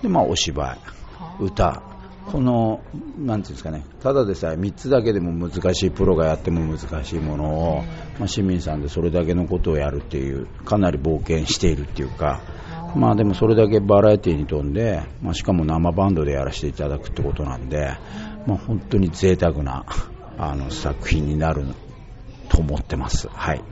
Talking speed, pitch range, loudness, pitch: 335 characters per minute, 75-100 Hz, -22 LUFS, 85 Hz